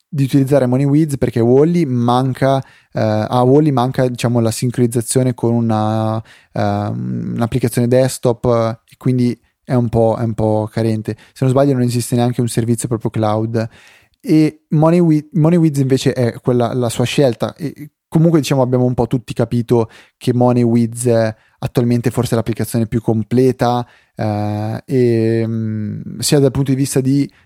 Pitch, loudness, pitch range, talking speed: 120 Hz, -16 LUFS, 115-135 Hz, 160 wpm